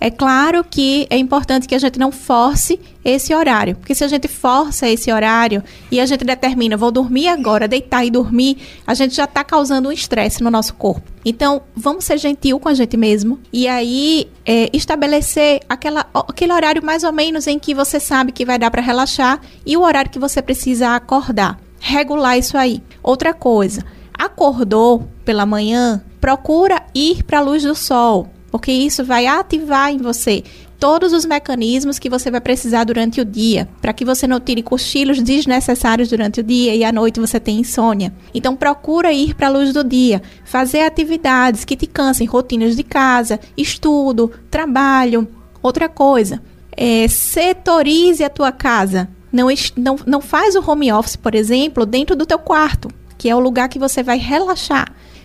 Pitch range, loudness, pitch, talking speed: 235-290 Hz, -15 LUFS, 260 Hz, 180 wpm